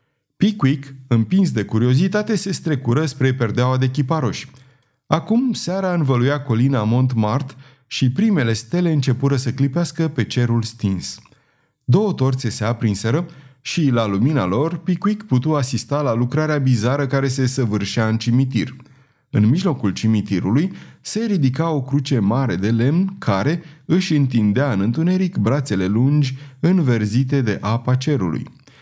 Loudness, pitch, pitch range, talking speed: -19 LUFS, 135 Hz, 120-155 Hz, 135 wpm